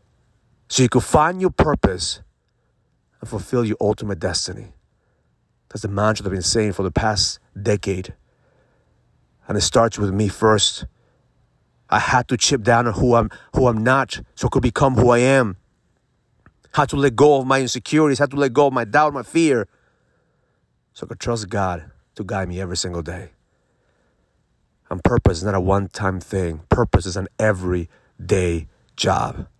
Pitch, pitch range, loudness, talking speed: 110 Hz, 95-125 Hz, -19 LUFS, 180 wpm